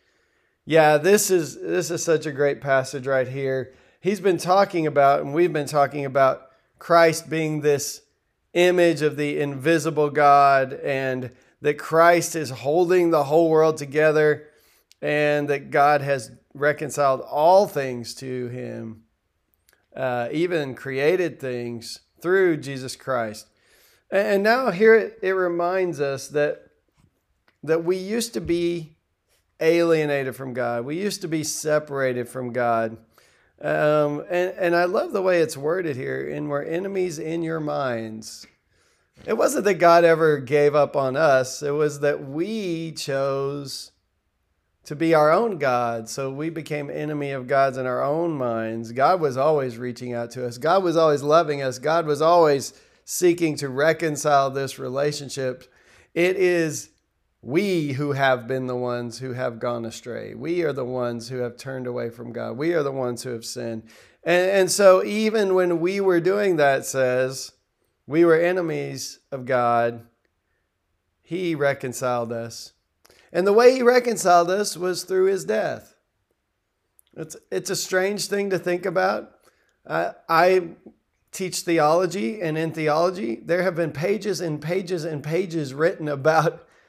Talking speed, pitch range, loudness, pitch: 155 wpm, 130-170 Hz, -22 LUFS, 150 Hz